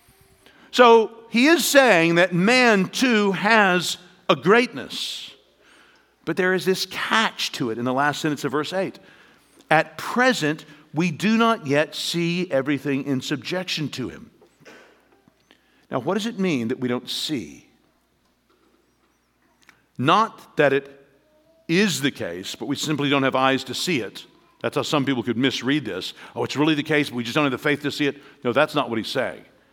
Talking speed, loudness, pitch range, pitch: 180 wpm, -21 LUFS, 140-195 Hz, 155 Hz